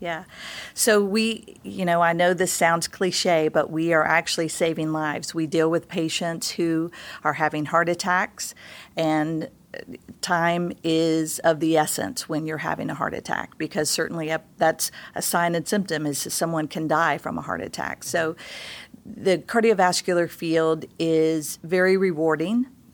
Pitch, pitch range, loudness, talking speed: 165 Hz, 160-180 Hz, -23 LUFS, 160 wpm